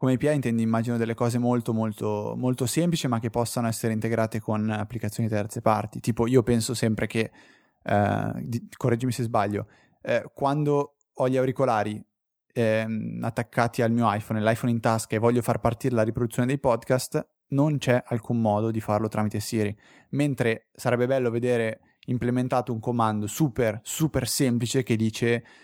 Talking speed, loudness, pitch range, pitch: 160 wpm, -26 LUFS, 110-125 Hz, 120 Hz